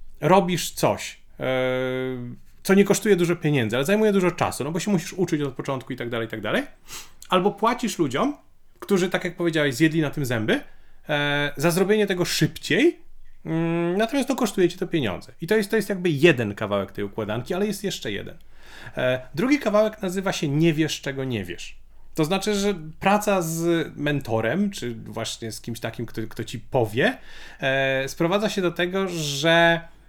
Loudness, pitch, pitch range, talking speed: -23 LUFS, 165 Hz, 130-195 Hz, 175 wpm